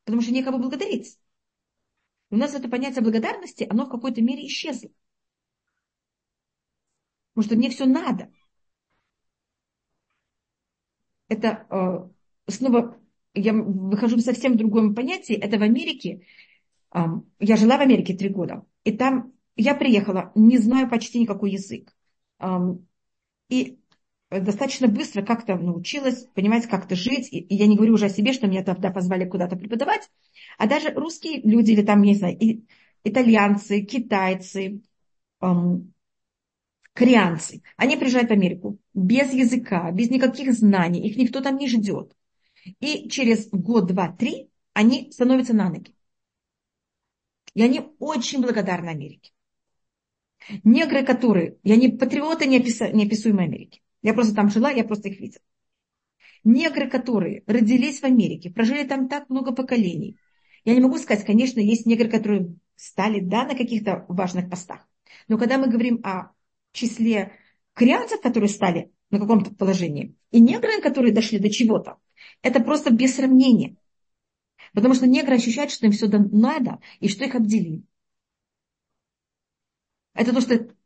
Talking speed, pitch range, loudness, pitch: 135 wpm, 200-255 Hz, -21 LUFS, 225 Hz